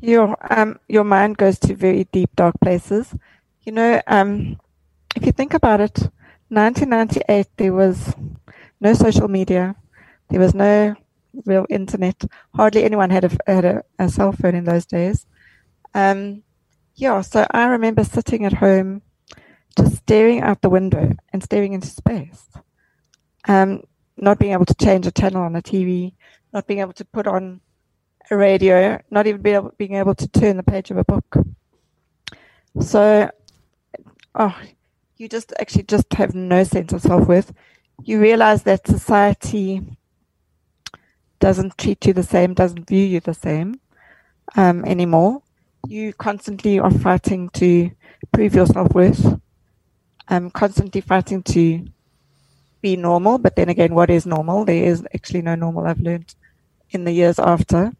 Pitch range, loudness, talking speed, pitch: 175-205 Hz, -17 LUFS, 155 wpm, 190 Hz